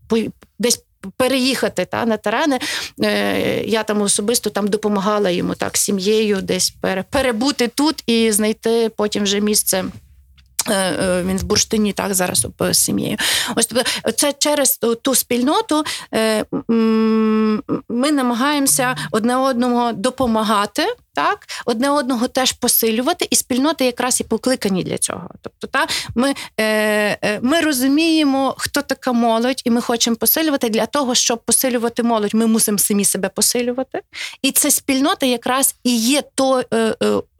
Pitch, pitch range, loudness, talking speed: 235 Hz, 215-265 Hz, -17 LUFS, 125 wpm